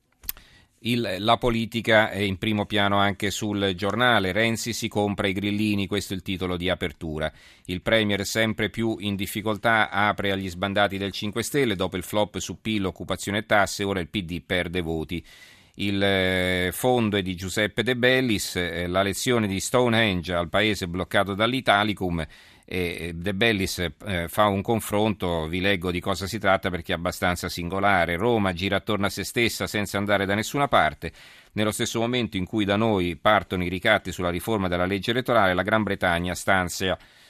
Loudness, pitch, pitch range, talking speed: -24 LUFS, 100 Hz, 90-110 Hz, 170 wpm